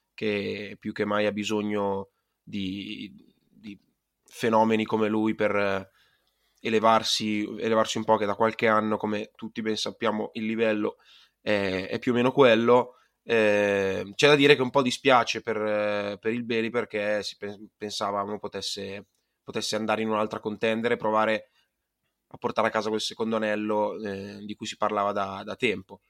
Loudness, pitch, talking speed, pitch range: -26 LUFS, 105 Hz, 165 wpm, 105-110 Hz